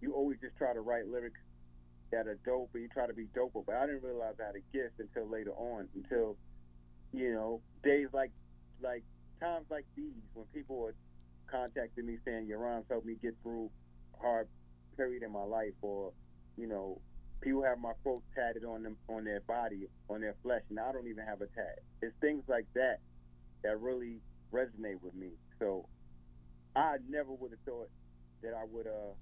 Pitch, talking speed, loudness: 110 Hz, 195 wpm, -40 LUFS